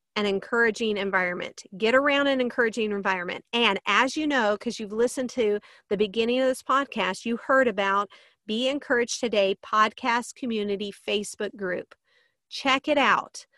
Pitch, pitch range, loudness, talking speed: 230 Hz, 205-255 Hz, -25 LUFS, 150 wpm